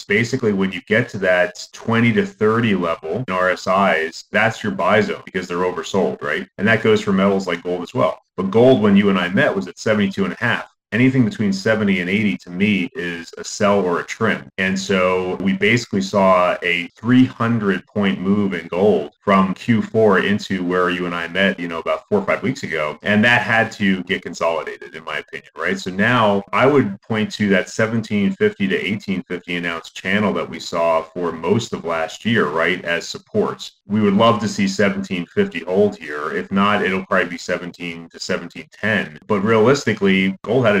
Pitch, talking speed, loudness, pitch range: 100 Hz, 205 wpm, -18 LUFS, 90-120 Hz